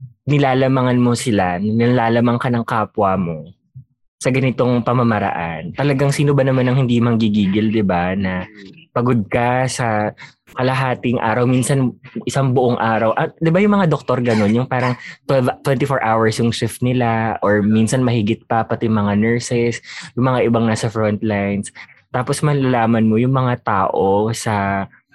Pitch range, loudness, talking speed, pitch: 110-130 Hz, -17 LUFS, 155 wpm, 120 Hz